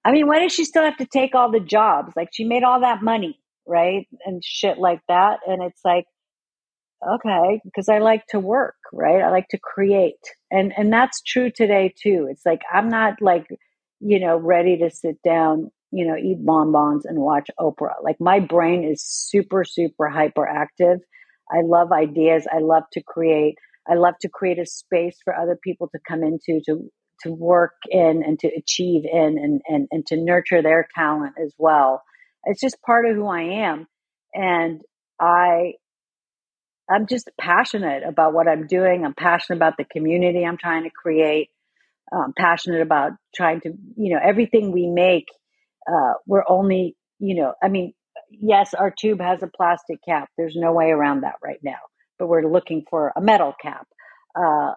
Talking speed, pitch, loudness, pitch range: 185 wpm, 175 Hz, -19 LUFS, 160-200 Hz